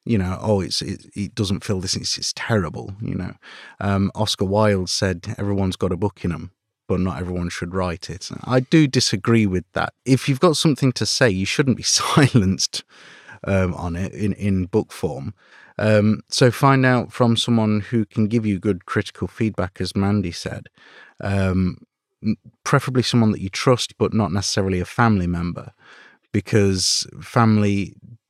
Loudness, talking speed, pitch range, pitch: -20 LUFS, 175 wpm, 95-115 Hz, 105 Hz